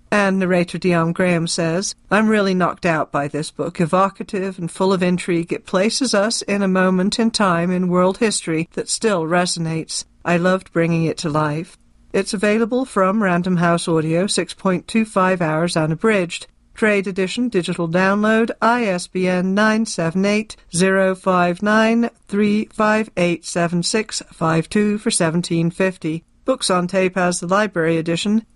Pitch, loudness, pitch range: 185 Hz, -18 LUFS, 170-210 Hz